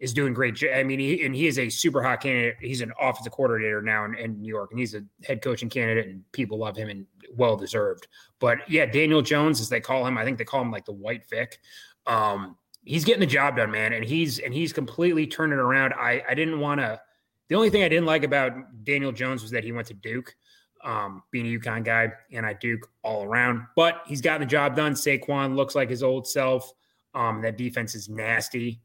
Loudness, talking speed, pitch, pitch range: -25 LUFS, 235 wpm, 130 Hz, 115-145 Hz